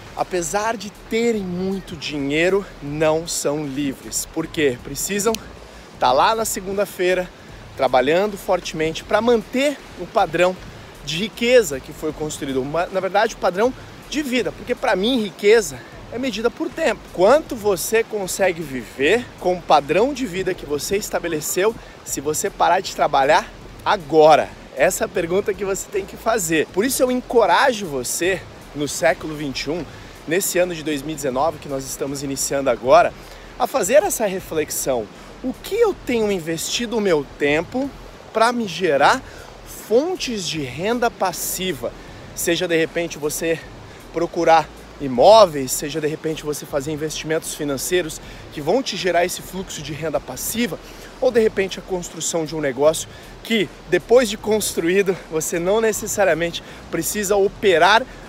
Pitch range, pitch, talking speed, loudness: 155-215 Hz, 180 Hz, 145 wpm, -20 LUFS